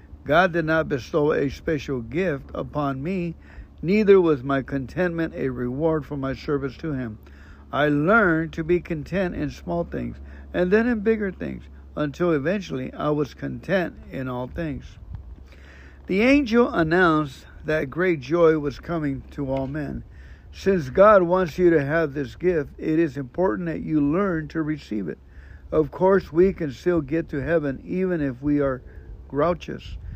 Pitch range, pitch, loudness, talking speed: 130-170 Hz, 150 Hz, -23 LUFS, 165 wpm